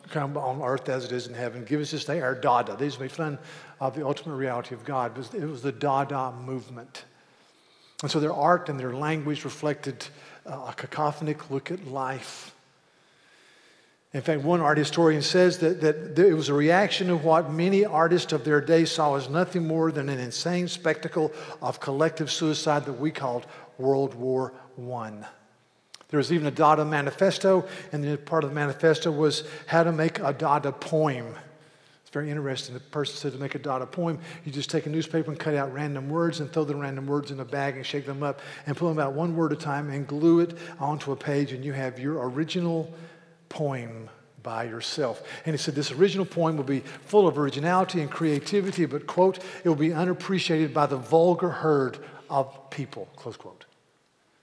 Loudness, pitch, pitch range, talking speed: -26 LUFS, 150 Hz, 140-165 Hz, 195 wpm